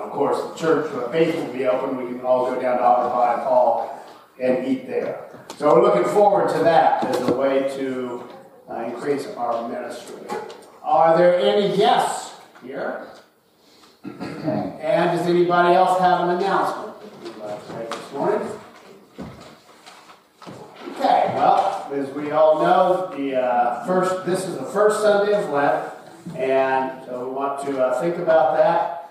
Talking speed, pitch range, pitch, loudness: 165 wpm, 130-185 Hz, 155 Hz, -20 LUFS